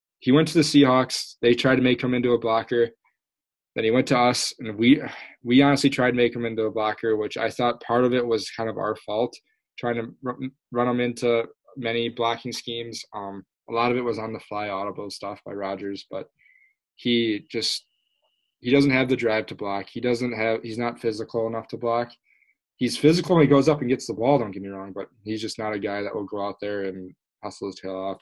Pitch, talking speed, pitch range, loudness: 115 Hz, 235 wpm, 105-125 Hz, -24 LUFS